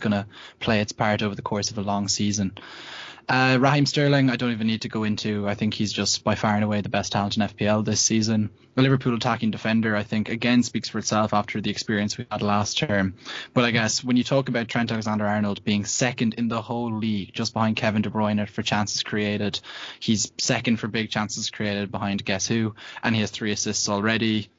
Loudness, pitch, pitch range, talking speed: -24 LUFS, 110 Hz, 105-115 Hz, 225 wpm